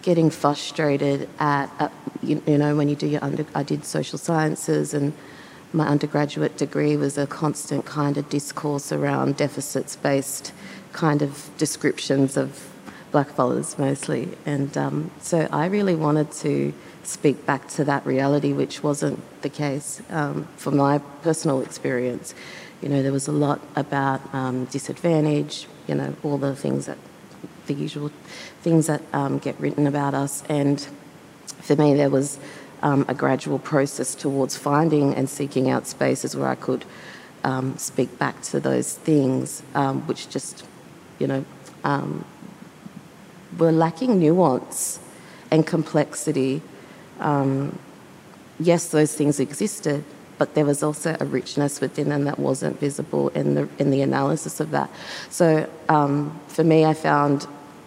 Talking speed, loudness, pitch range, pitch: 150 wpm, -23 LUFS, 135-150 Hz, 145 Hz